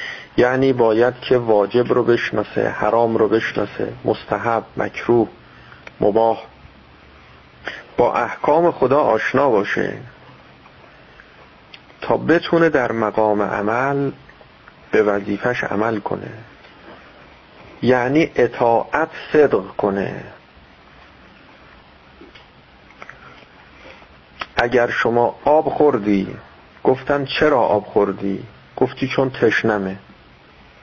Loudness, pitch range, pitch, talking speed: -18 LUFS, 100-125 Hz, 115 Hz, 80 wpm